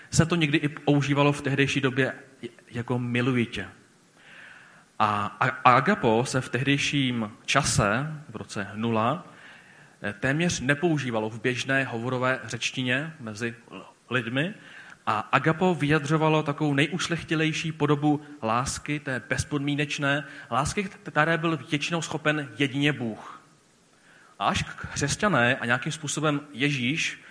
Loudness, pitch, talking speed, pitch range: -26 LUFS, 140 Hz, 110 wpm, 125-150 Hz